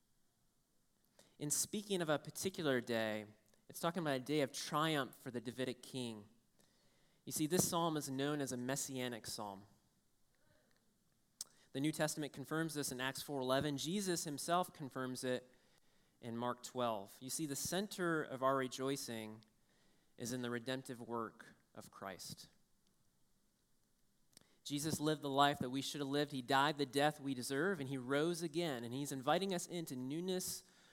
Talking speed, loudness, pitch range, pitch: 155 wpm, -40 LUFS, 125-155 Hz, 140 Hz